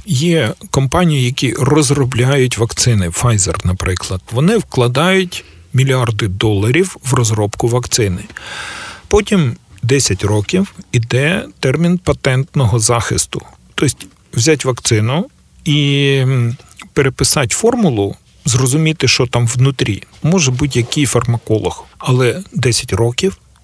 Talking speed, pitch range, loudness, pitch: 95 wpm, 115-145 Hz, -14 LUFS, 130 Hz